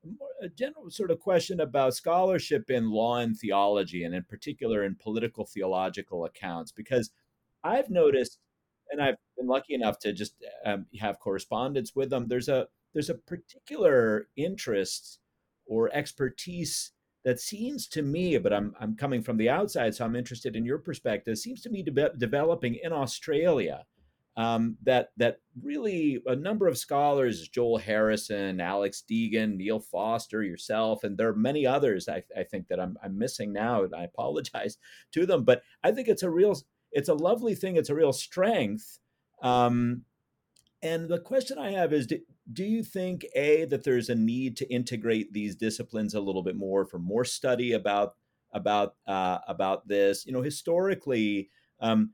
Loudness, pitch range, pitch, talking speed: -29 LUFS, 110-165 Hz, 125 Hz, 170 wpm